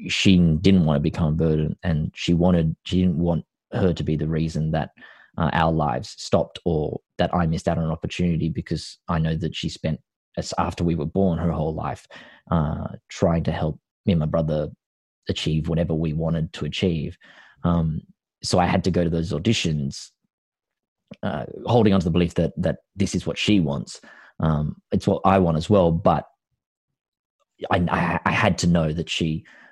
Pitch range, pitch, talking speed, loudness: 80-90 Hz, 85 Hz, 195 wpm, -23 LUFS